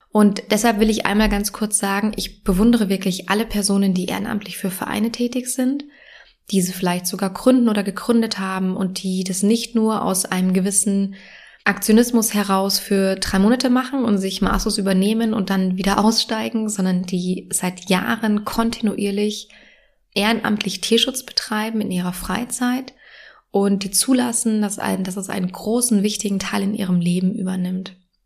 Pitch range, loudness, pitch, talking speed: 195-225 Hz, -20 LUFS, 205 Hz, 160 wpm